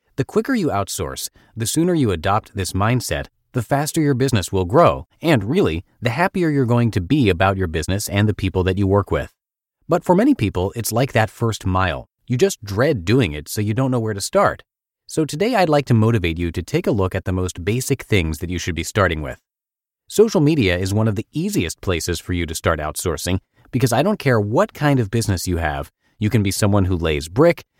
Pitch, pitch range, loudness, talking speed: 105 Hz, 95-130 Hz, -19 LUFS, 230 wpm